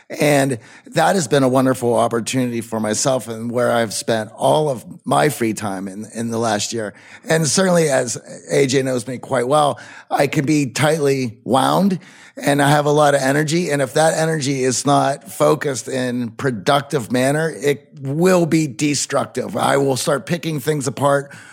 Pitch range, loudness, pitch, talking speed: 125-150 Hz, -18 LUFS, 140 Hz, 175 wpm